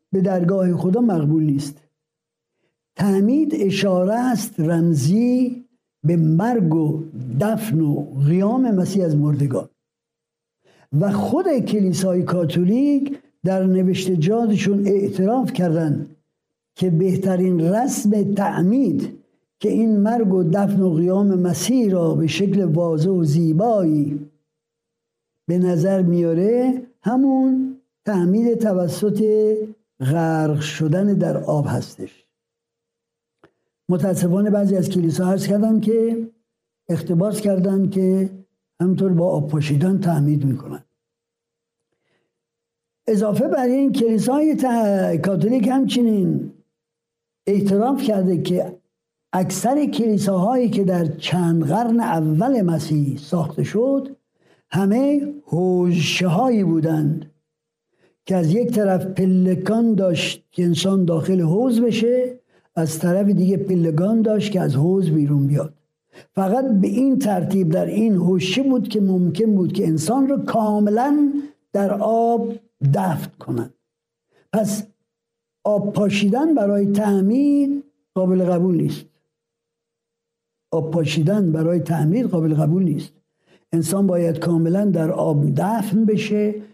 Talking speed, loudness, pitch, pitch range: 110 wpm, -19 LUFS, 190 Hz, 165-220 Hz